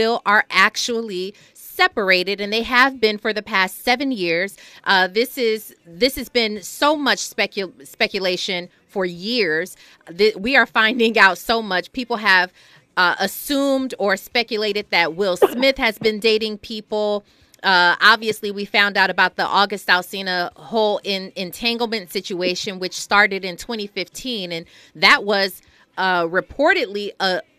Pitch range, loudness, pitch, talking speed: 185-230 Hz, -18 LUFS, 205 Hz, 145 wpm